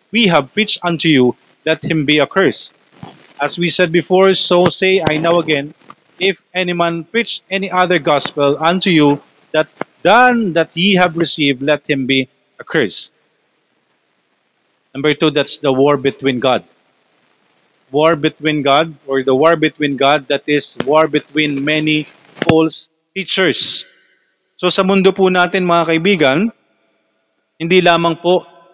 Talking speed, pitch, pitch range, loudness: 145 wpm, 160 Hz, 145-180 Hz, -14 LUFS